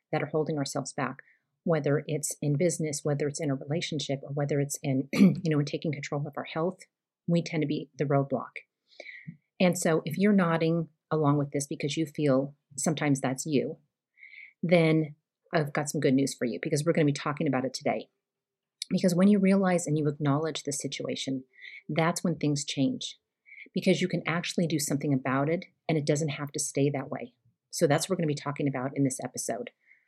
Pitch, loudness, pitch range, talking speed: 150 Hz, -29 LUFS, 140-165 Hz, 205 wpm